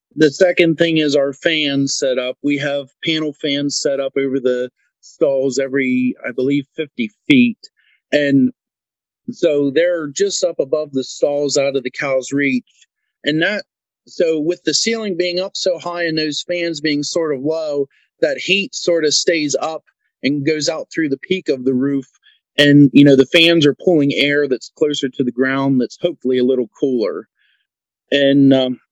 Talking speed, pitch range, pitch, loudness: 180 wpm, 135-170 Hz, 145 Hz, -16 LUFS